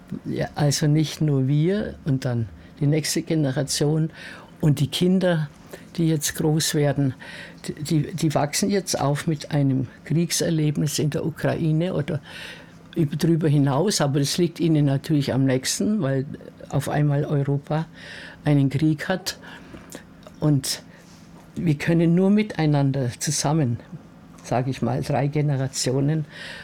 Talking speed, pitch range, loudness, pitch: 125 wpm, 140-165 Hz, -23 LUFS, 150 Hz